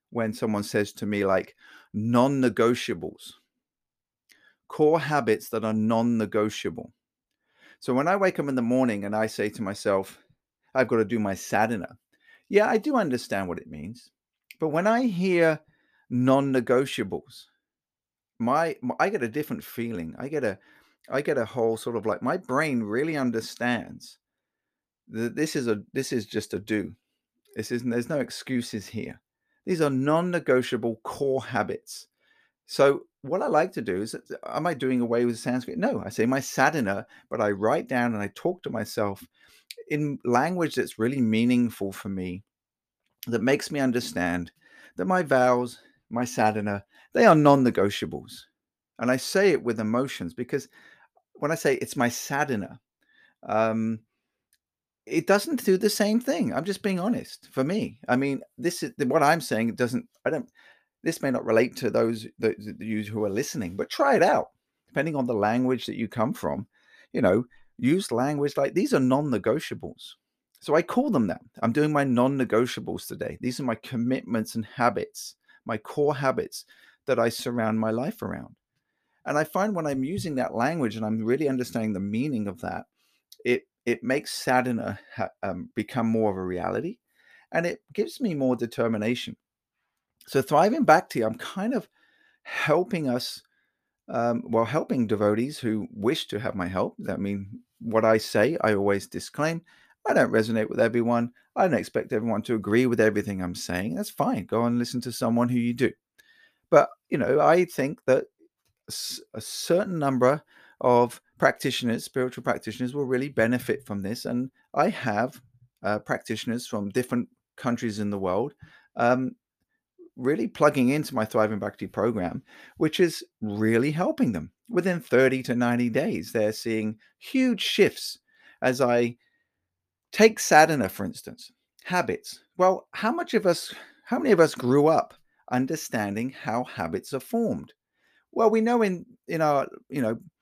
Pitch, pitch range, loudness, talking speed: 125 Hz, 110-150 Hz, -26 LUFS, 170 wpm